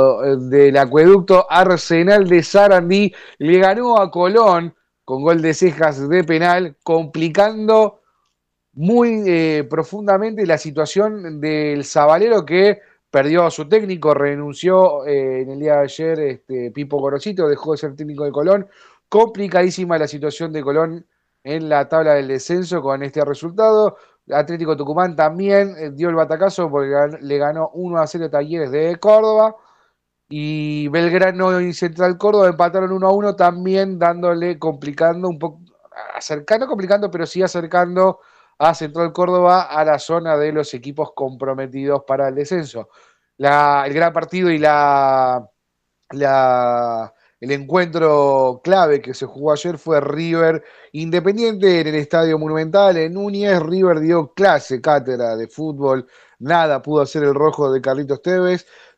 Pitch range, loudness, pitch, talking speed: 145-180 Hz, -16 LUFS, 160 Hz, 145 wpm